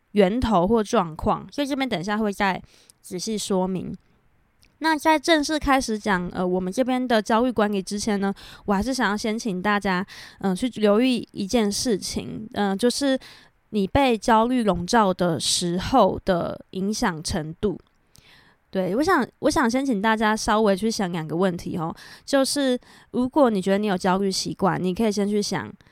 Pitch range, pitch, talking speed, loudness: 190-245 Hz, 210 Hz, 255 characters per minute, -23 LUFS